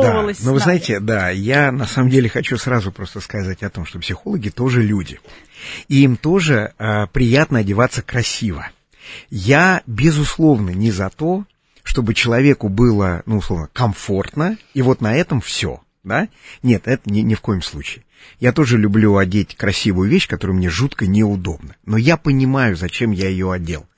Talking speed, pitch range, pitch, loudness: 170 wpm, 100-130 Hz, 110 Hz, -17 LUFS